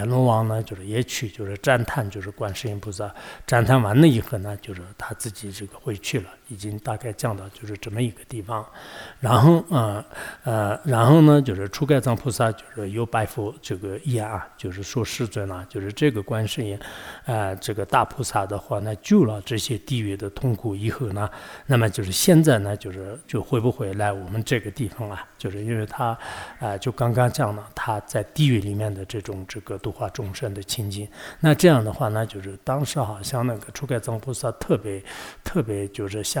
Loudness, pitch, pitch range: -23 LUFS, 110 Hz, 100-125 Hz